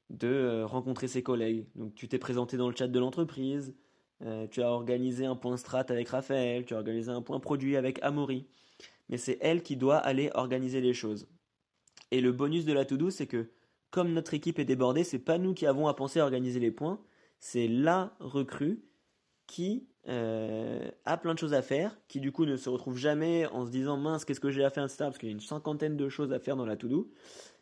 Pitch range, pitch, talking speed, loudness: 125-150 Hz, 130 Hz, 230 wpm, -32 LUFS